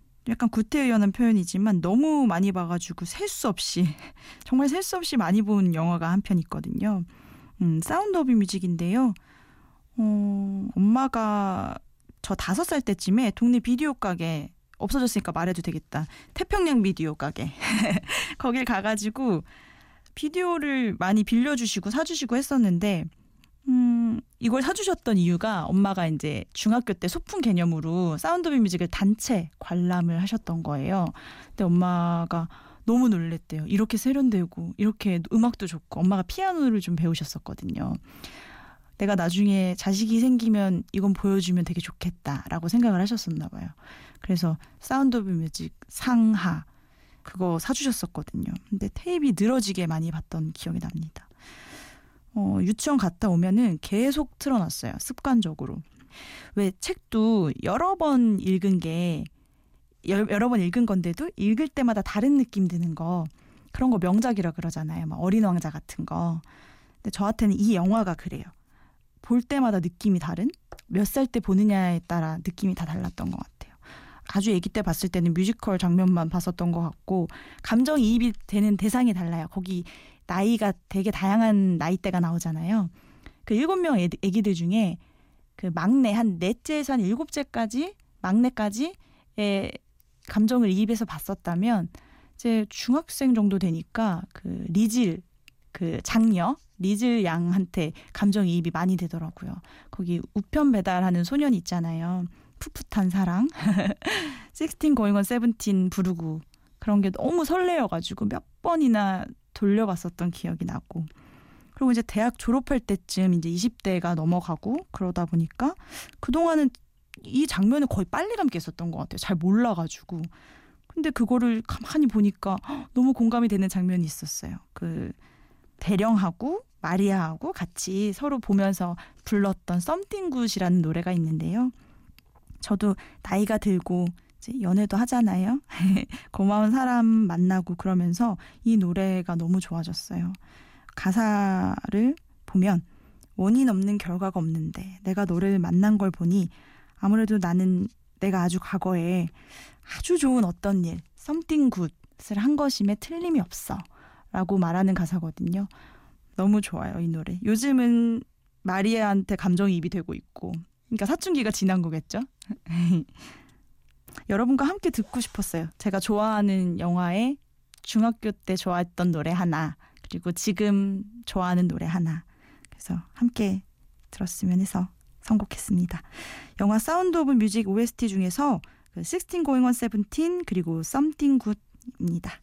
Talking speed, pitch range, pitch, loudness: 310 characters per minute, 175-235 Hz, 200 Hz, -25 LUFS